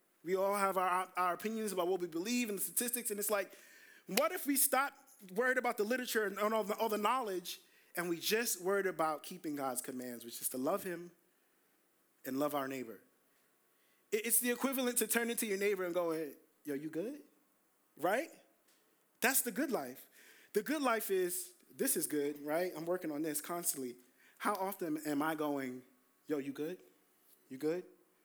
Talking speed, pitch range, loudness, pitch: 190 wpm, 155-235 Hz, -36 LUFS, 190 Hz